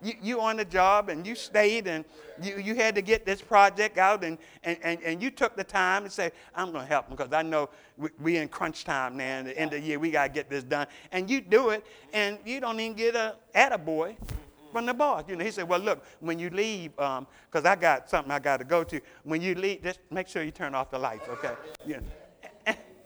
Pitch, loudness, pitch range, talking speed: 180 Hz, -28 LUFS, 155-210 Hz, 265 wpm